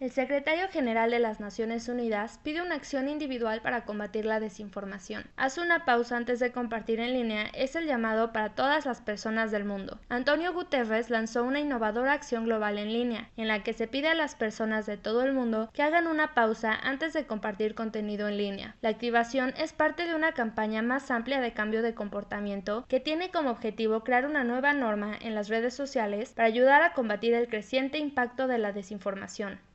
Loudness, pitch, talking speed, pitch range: -29 LUFS, 235 Hz, 200 wpm, 220-270 Hz